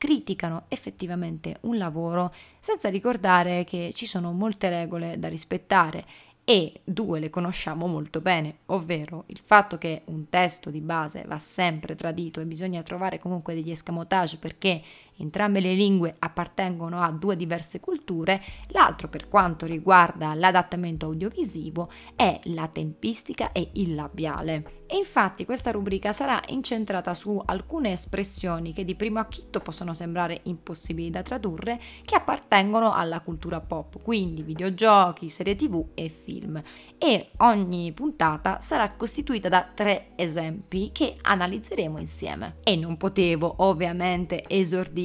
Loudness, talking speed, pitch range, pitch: -26 LUFS, 135 wpm, 165-200 Hz, 180 Hz